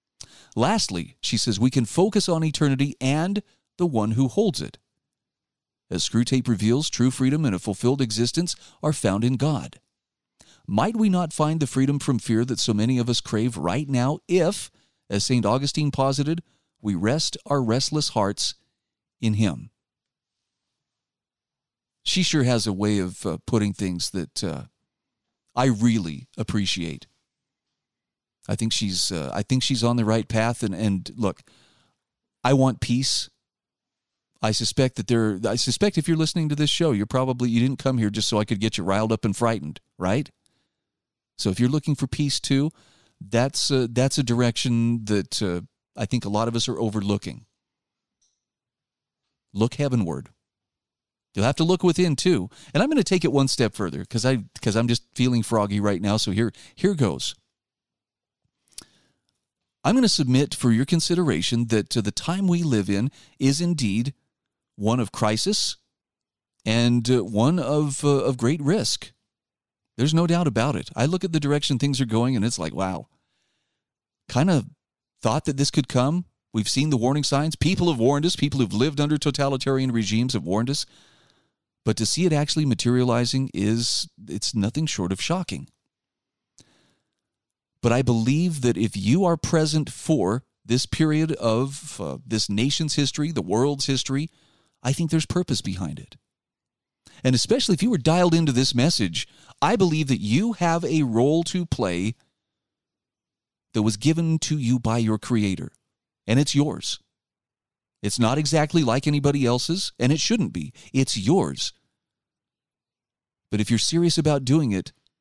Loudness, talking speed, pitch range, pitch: -23 LUFS, 165 wpm, 110-150 Hz, 125 Hz